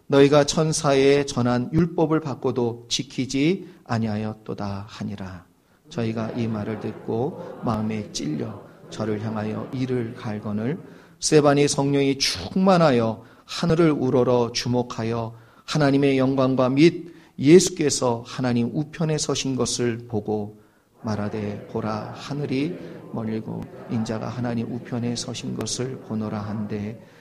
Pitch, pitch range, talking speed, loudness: 120 Hz, 110-140 Hz, 270 characters per minute, -23 LUFS